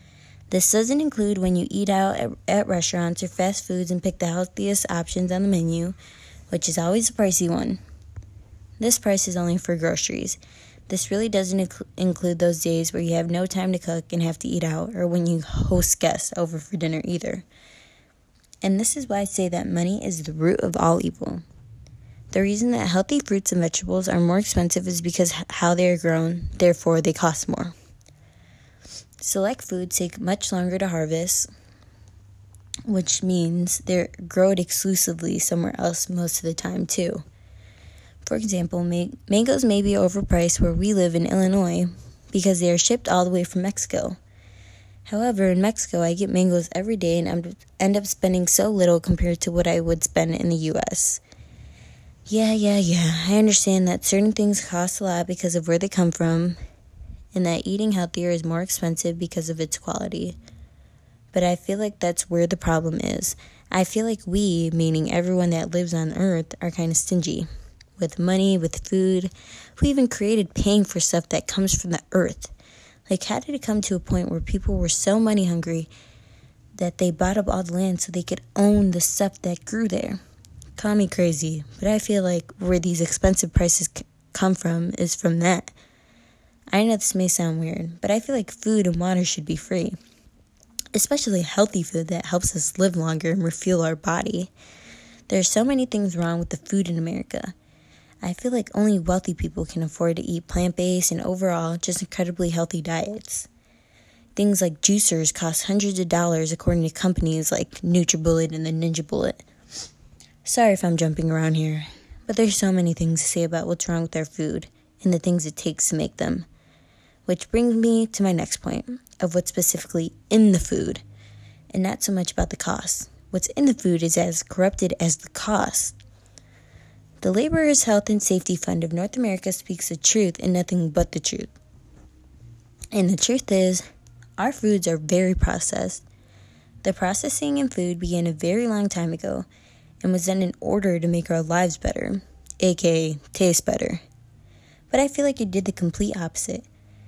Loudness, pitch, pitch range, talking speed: -23 LUFS, 180 Hz, 165-195 Hz, 185 wpm